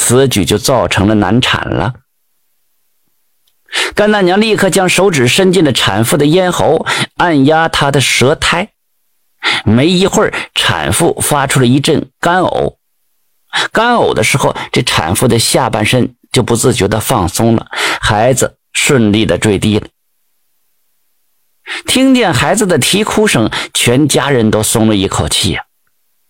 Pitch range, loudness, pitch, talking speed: 110-170 Hz, -11 LUFS, 125 Hz, 205 characters per minute